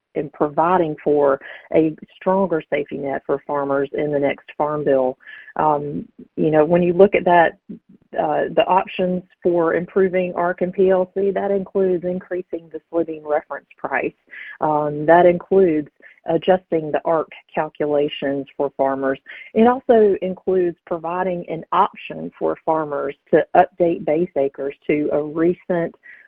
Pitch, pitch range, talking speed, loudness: 165 Hz, 145-180 Hz, 140 wpm, -19 LUFS